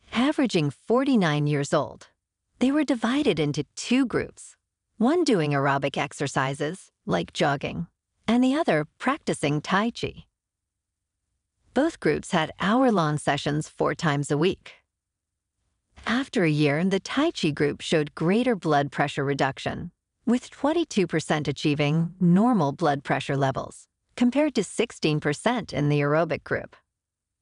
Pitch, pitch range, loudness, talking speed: 155 Hz, 140-225 Hz, -25 LUFS, 125 wpm